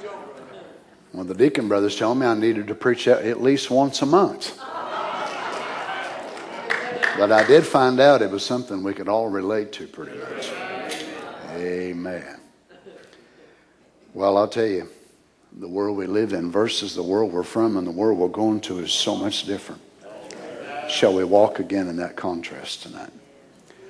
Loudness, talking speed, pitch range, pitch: -22 LUFS, 160 wpm, 95-125 Hz, 105 Hz